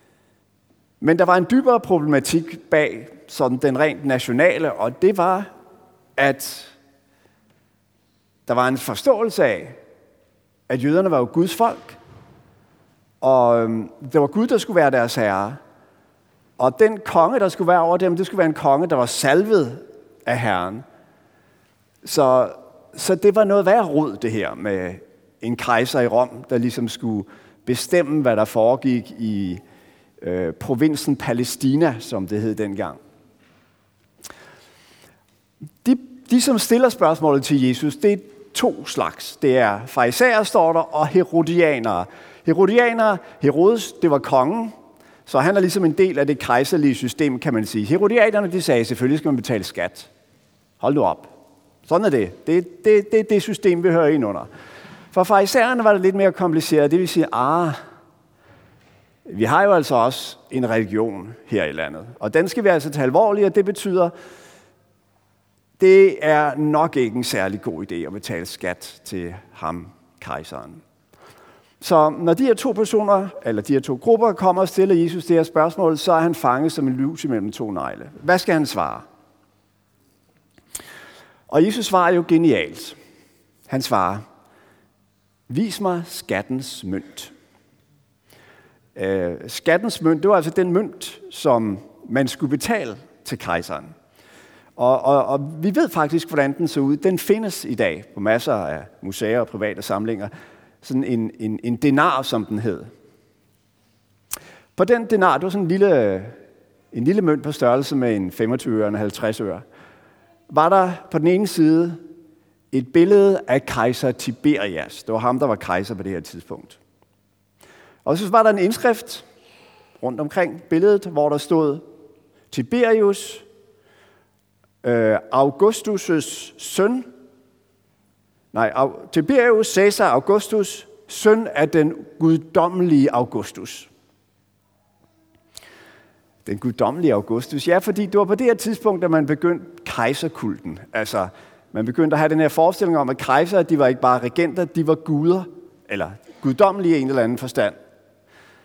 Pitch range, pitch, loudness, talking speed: 120-185 Hz, 155 Hz, -19 LUFS, 155 wpm